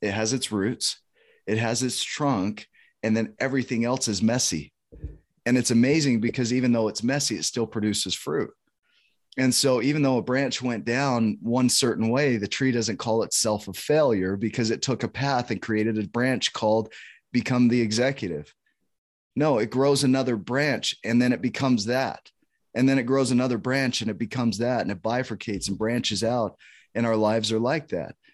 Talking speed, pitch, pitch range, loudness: 190 wpm, 120 Hz, 110-130 Hz, -24 LUFS